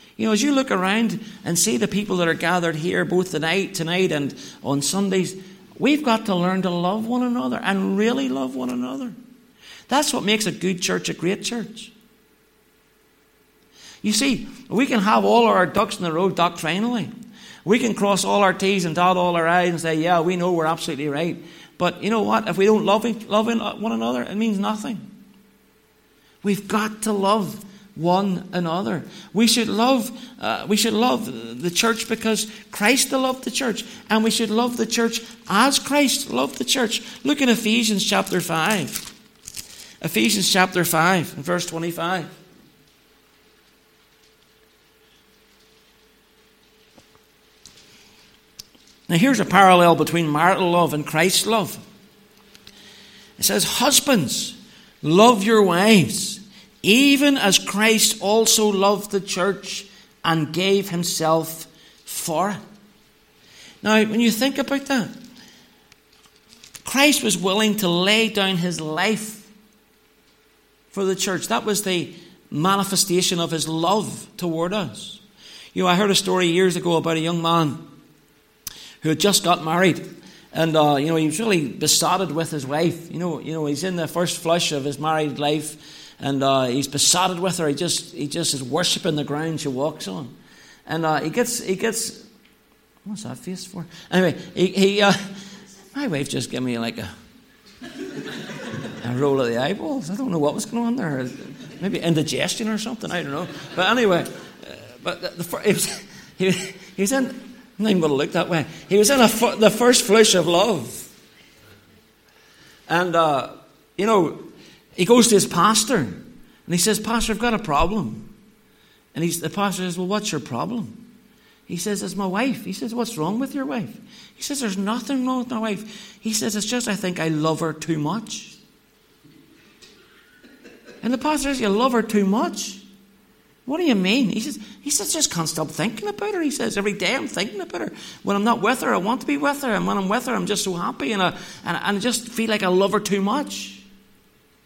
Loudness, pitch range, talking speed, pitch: -20 LUFS, 175-225 Hz, 180 wpm, 200 Hz